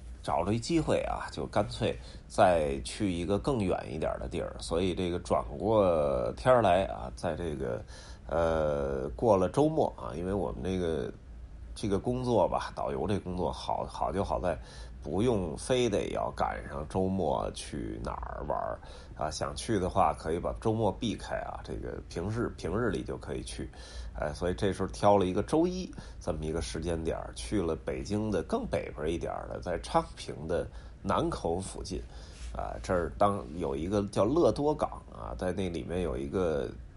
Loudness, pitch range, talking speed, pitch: -31 LUFS, 75-100 Hz, 255 characters per minute, 90 Hz